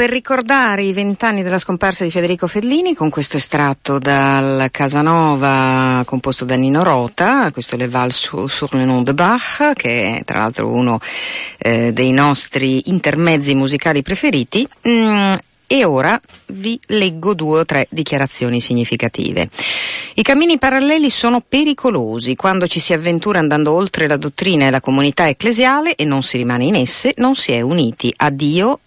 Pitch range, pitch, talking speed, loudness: 135-210 Hz, 155 Hz, 160 wpm, -15 LUFS